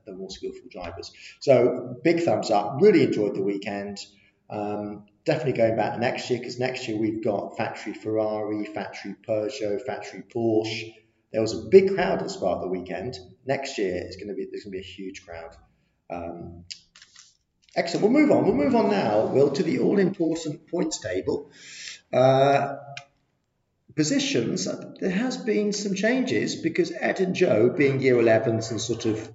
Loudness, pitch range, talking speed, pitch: -24 LUFS, 105-155 Hz, 170 wpm, 115 Hz